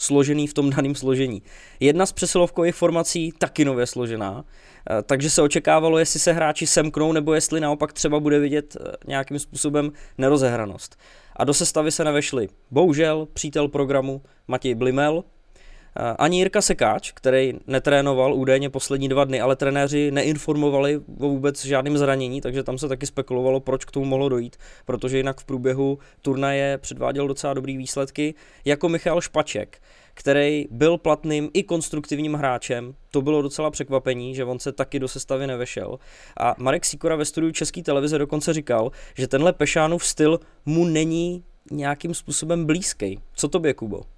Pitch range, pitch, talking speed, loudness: 135-155 Hz, 145 Hz, 155 wpm, -22 LUFS